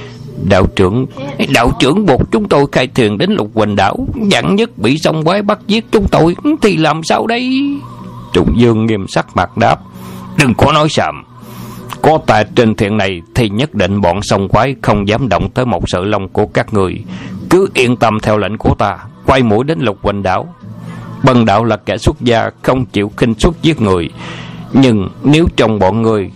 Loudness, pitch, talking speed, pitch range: -12 LUFS, 115 Hz, 200 wpm, 100-140 Hz